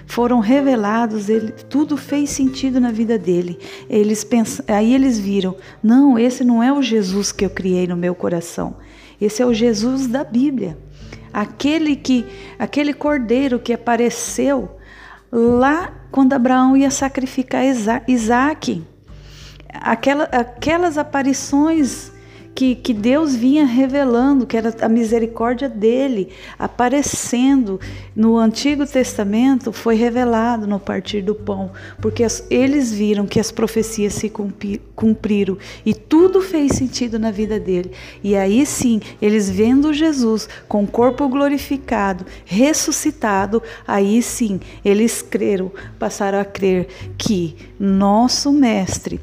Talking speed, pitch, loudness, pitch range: 125 wpm, 235 Hz, -17 LUFS, 210-270 Hz